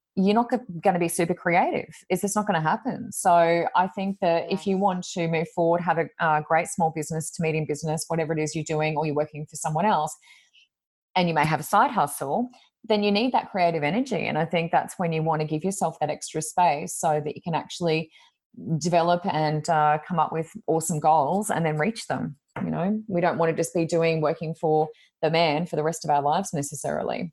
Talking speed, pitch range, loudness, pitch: 235 wpm, 155-185 Hz, -25 LUFS, 165 Hz